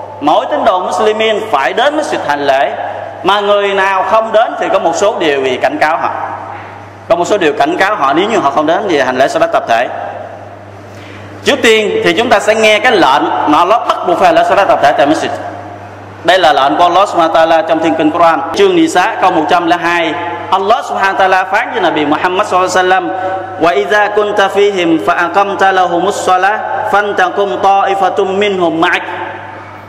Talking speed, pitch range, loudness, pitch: 195 wpm, 175-215 Hz, -10 LUFS, 195 Hz